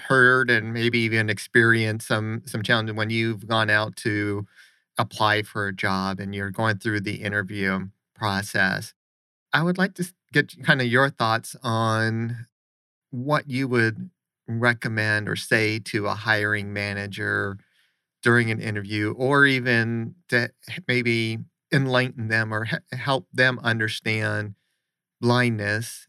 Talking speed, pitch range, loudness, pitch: 135 wpm, 105-125 Hz, -23 LUFS, 110 Hz